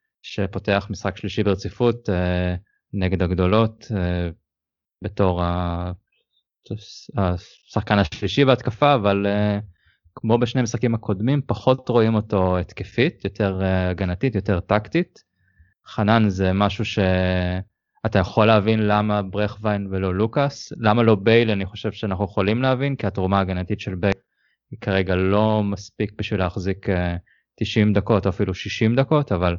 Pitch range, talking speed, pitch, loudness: 95-110 Hz, 120 wpm, 100 Hz, -21 LUFS